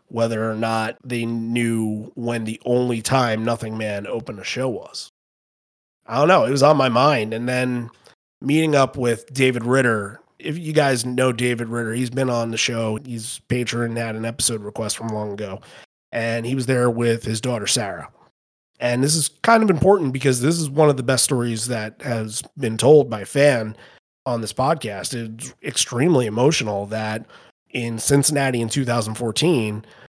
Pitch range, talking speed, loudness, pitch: 115-135 Hz, 180 wpm, -20 LUFS, 120 Hz